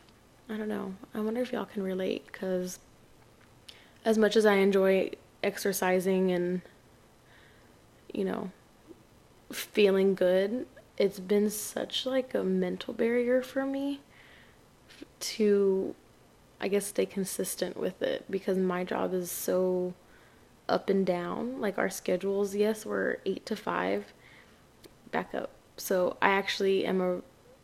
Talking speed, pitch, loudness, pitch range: 130 wpm, 195 Hz, -30 LUFS, 185-220 Hz